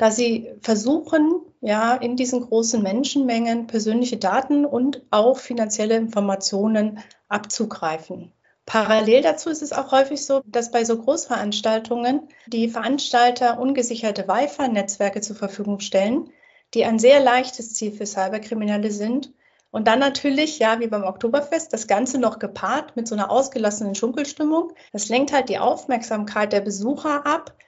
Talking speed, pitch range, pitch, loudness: 140 wpm, 215-270 Hz, 235 Hz, -21 LUFS